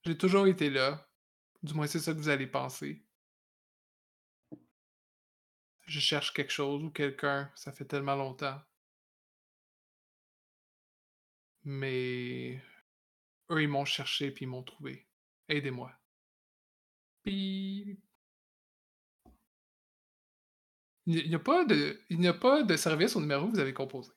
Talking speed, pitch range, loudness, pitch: 115 wpm, 135-170 Hz, -32 LUFS, 145 Hz